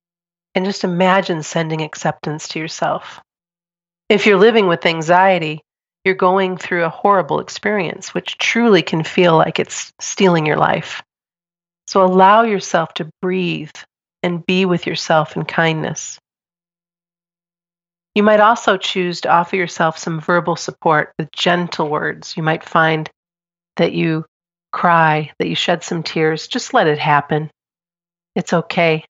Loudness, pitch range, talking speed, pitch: -16 LUFS, 160-185 Hz, 140 wpm, 175 Hz